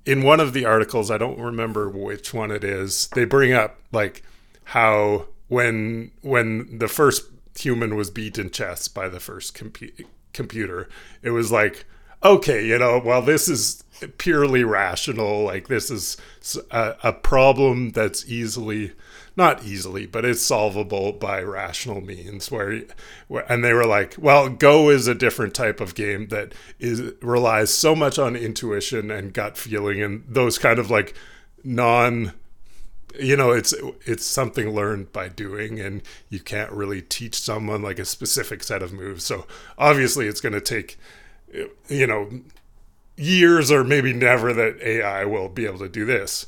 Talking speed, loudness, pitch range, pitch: 165 wpm, -20 LUFS, 105-130 Hz, 115 Hz